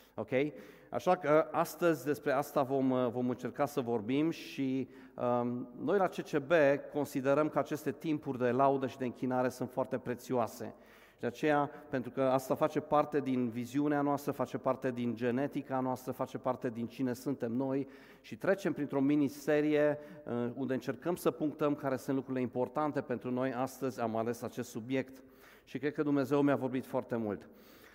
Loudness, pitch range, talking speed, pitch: -34 LUFS, 125-145 Hz, 165 wpm, 135 Hz